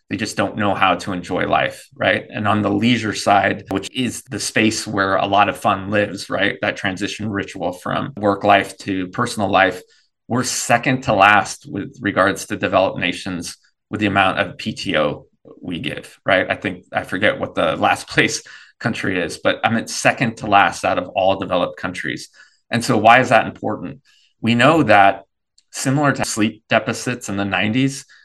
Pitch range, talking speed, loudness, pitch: 100-120 Hz, 185 wpm, -18 LUFS, 105 Hz